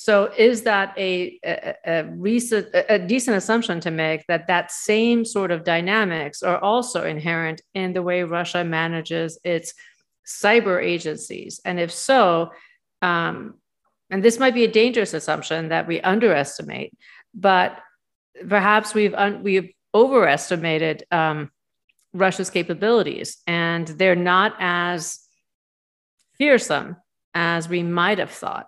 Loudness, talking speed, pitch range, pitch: -21 LUFS, 130 wpm, 165-210 Hz, 180 Hz